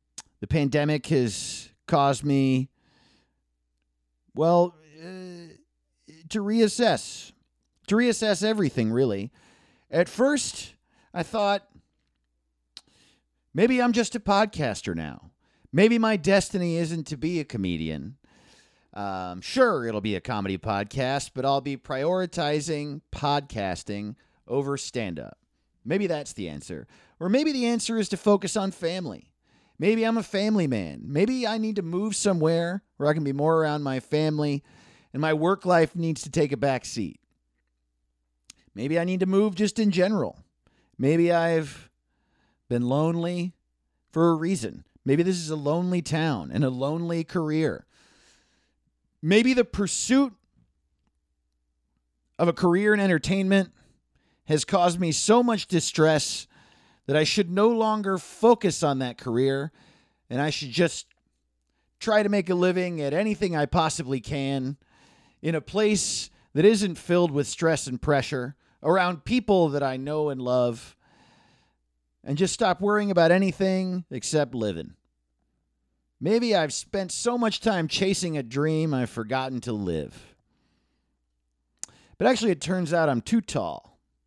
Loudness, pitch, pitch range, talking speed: -25 LUFS, 155 Hz, 120-190 Hz, 140 wpm